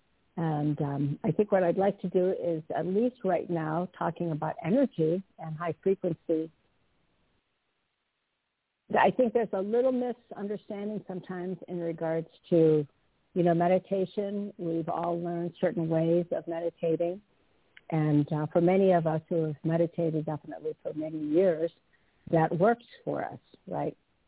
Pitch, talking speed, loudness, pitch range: 170 Hz, 145 wpm, -29 LUFS, 160-195 Hz